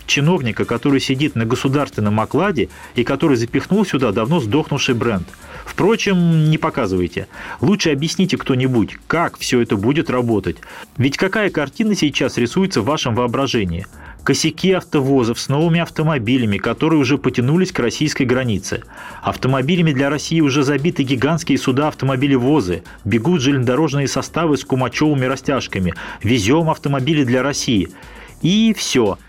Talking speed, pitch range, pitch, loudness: 130 wpm, 125-155 Hz, 140 Hz, -17 LUFS